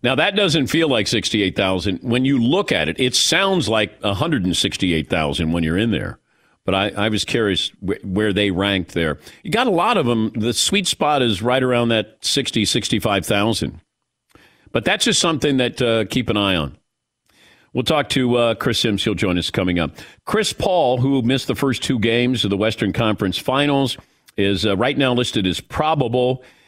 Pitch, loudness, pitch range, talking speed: 115 Hz, -18 LUFS, 100-130 Hz, 190 wpm